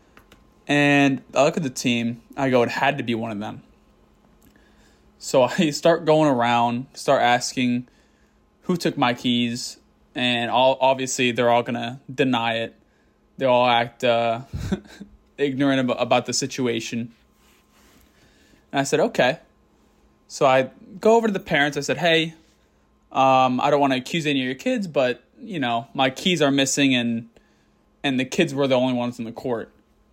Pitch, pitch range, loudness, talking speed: 130 Hz, 120-140 Hz, -21 LUFS, 165 wpm